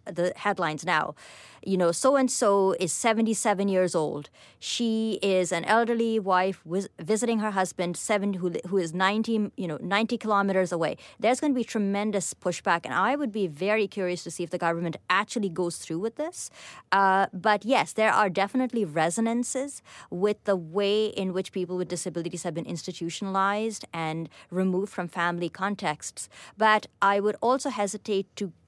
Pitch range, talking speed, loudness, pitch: 180-215 Hz, 170 wpm, -27 LUFS, 195 Hz